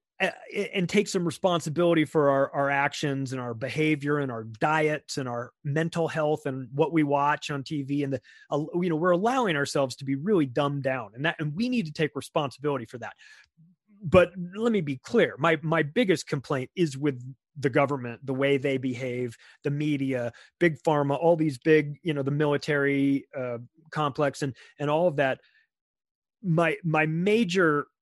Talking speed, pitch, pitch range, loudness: 180 wpm, 150 Hz, 140-165 Hz, -27 LUFS